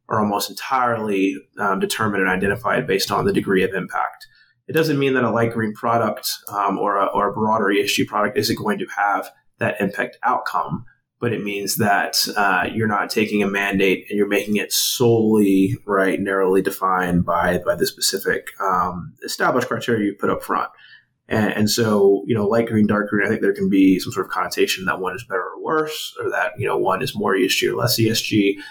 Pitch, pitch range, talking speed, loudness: 105 Hz, 95-115 Hz, 210 wpm, -20 LUFS